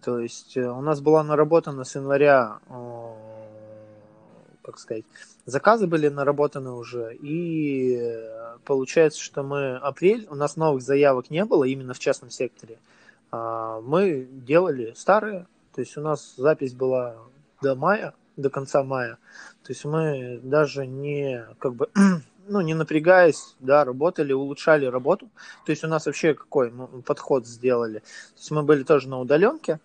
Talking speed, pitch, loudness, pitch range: 145 wpm, 140 Hz, -23 LUFS, 125-155 Hz